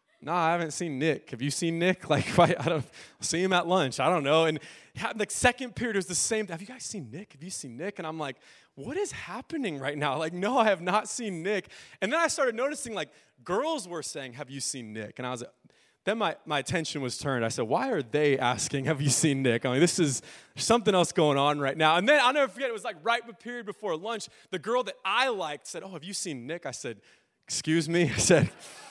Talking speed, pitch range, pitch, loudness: 255 wpm, 145-210 Hz, 170 Hz, -28 LUFS